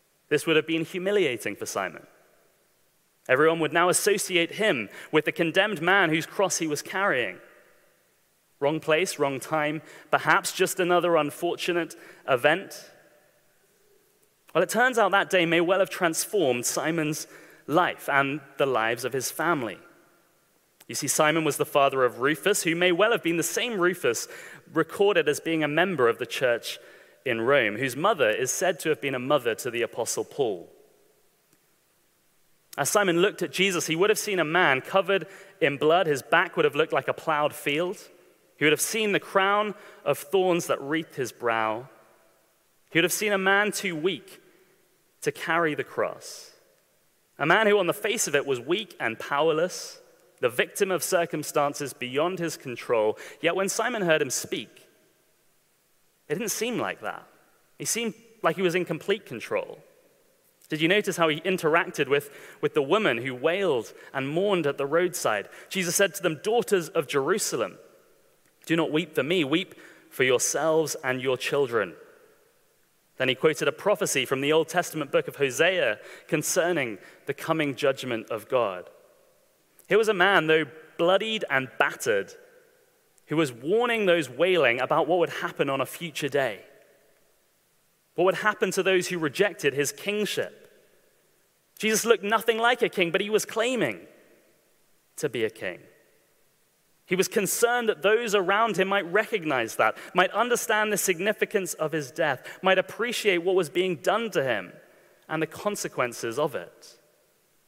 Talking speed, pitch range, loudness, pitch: 165 wpm, 160-240 Hz, -25 LUFS, 190 Hz